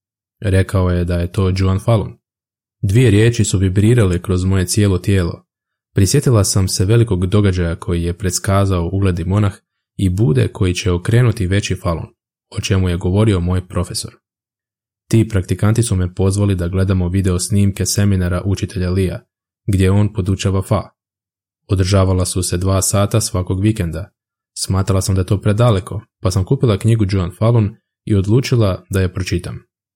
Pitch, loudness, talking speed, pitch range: 95 Hz, -16 LUFS, 155 wpm, 95-110 Hz